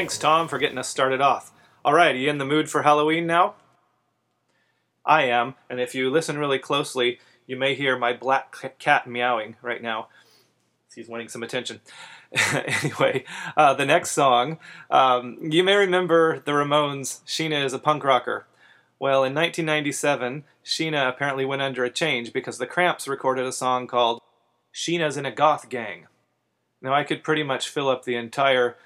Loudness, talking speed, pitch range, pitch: -23 LUFS, 175 wpm, 125-150 Hz, 135 Hz